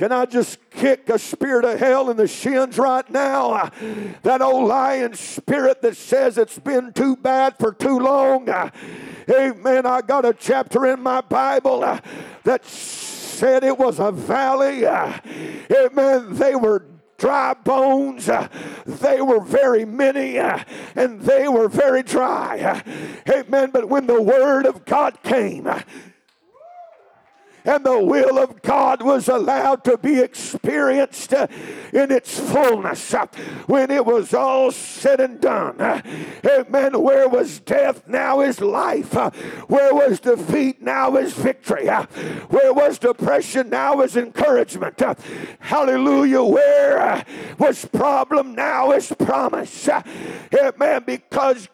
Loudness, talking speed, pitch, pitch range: -18 LUFS, 130 wpm, 265 Hz, 250-275 Hz